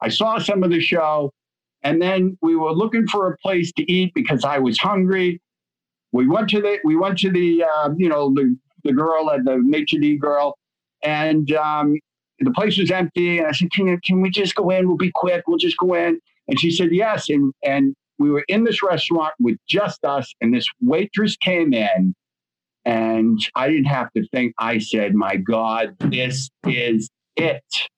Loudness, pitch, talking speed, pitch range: -19 LUFS, 160 Hz, 195 wpm, 130-185 Hz